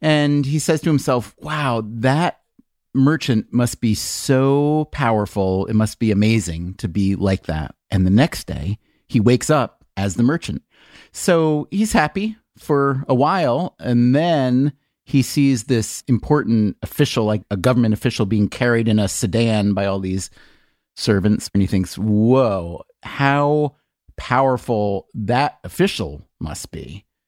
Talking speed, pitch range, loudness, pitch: 145 wpm, 105-140 Hz, -19 LUFS, 120 Hz